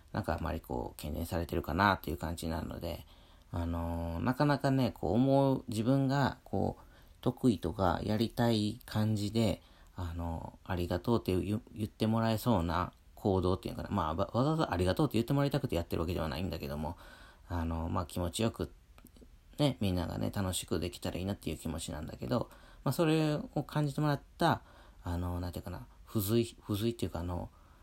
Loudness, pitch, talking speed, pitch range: -34 LUFS, 100 Hz, 410 characters per minute, 85-120 Hz